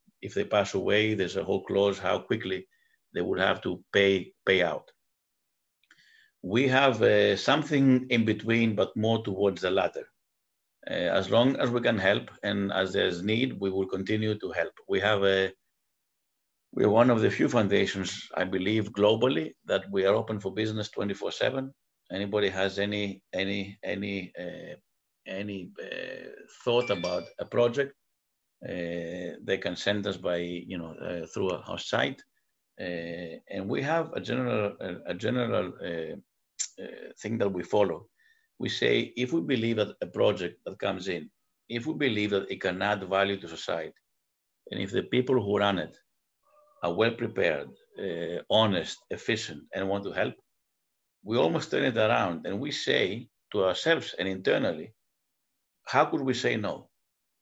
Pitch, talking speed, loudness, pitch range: 105 Hz, 165 wpm, -28 LUFS, 95-125 Hz